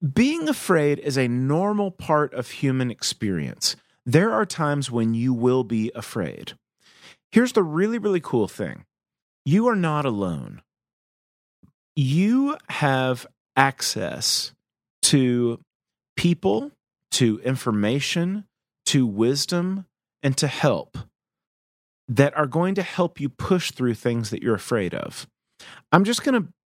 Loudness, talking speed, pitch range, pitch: -23 LUFS, 125 wpm, 125-185 Hz, 145 Hz